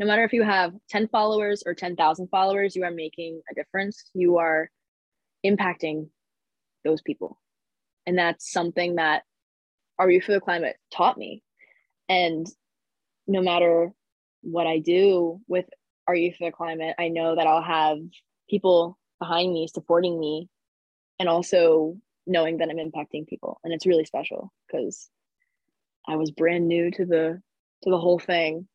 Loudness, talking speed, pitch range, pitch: -24 LUFS, 155 wpm, 165-185 Hz, 175 Hz